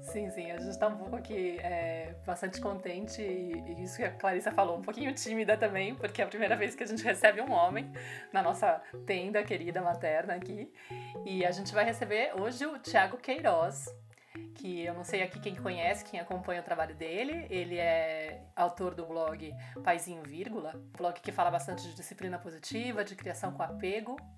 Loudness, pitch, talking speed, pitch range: -34 LUFS, 180 Hz, 190 wpm, 170-210 Hz